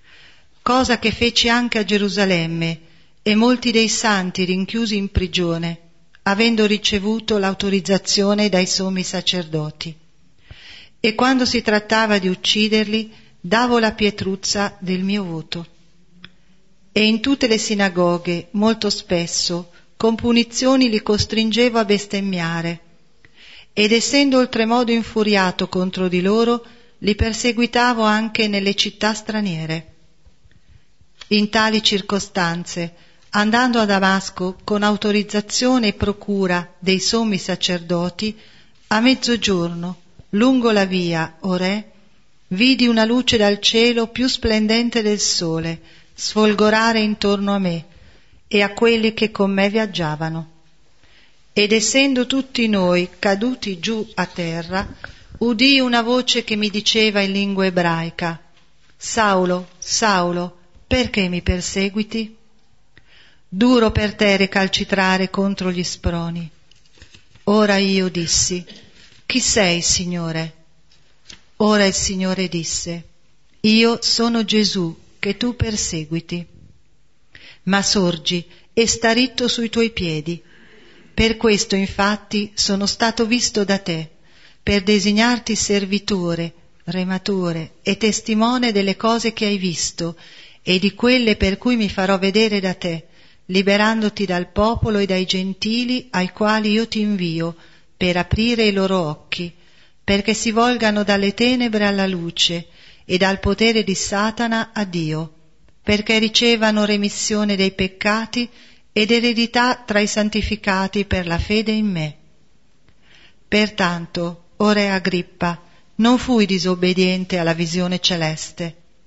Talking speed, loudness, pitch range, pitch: 120 wpm, -18 LUFS, 180-220 Hz, 200 Hz